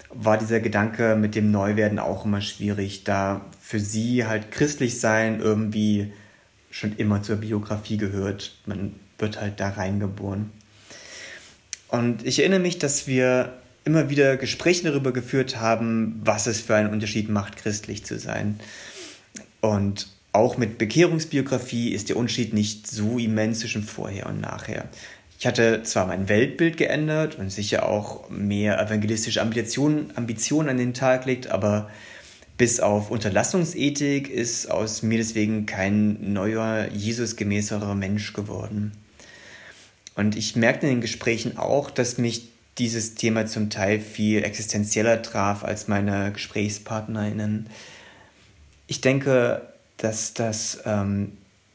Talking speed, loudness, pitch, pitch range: 130 wpm, -24 LUFS, 110 Hz, 105-120 Hz